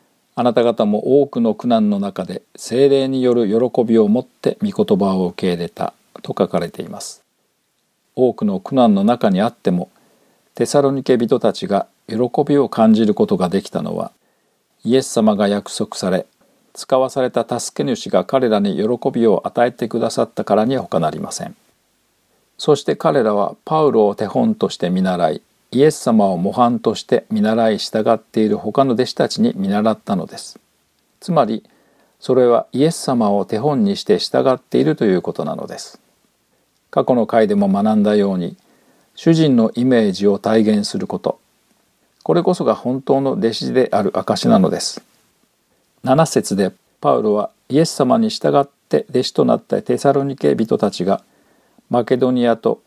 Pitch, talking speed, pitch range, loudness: 125 Hz, 315 characters per minute, 110-140 Hz, -17 LUFS